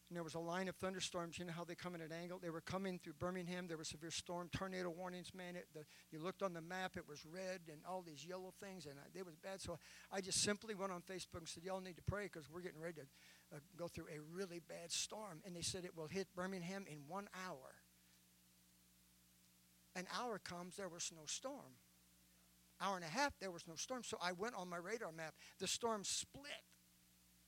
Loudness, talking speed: -48 LUFS, 235 wpm